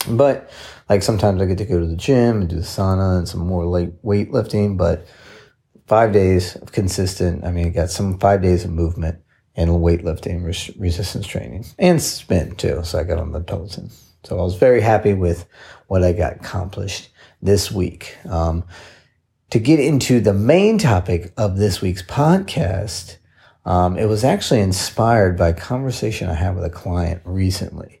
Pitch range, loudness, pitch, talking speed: 85-105 Hz, -18 LUFS, 95 Hz, 185 wpm